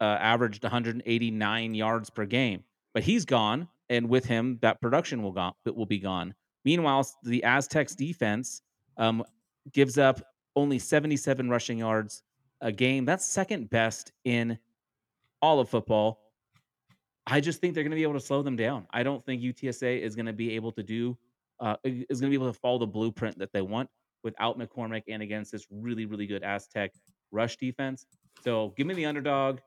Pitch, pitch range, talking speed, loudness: 120 Hz, 110-135 Hz, 185 wpm, -29 LUFS